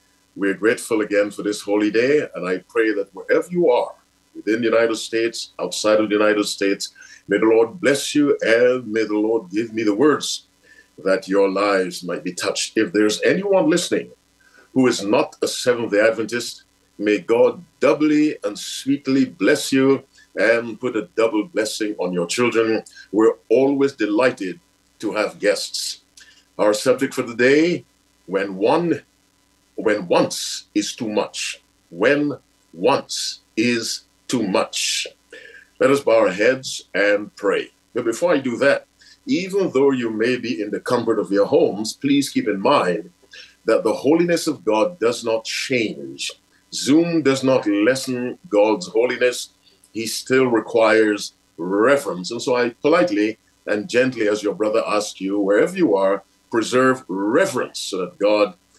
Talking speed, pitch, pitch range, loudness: 160 wpm, 115 Hz, 105-145 Hz, -20 LUFS